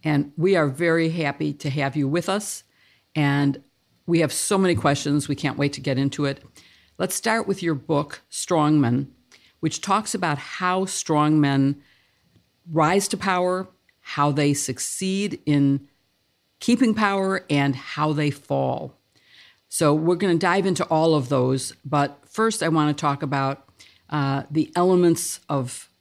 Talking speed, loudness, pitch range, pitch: 155 wpm, -23 LUFS, 140-180 Hz, 150 Hz